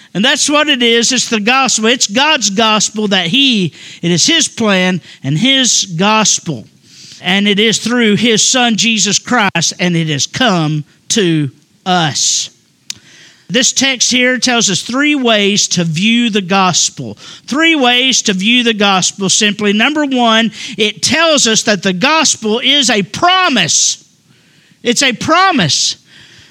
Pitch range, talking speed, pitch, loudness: 185-250 Hz, 150 wpm, 215 Hz, -10 LUFS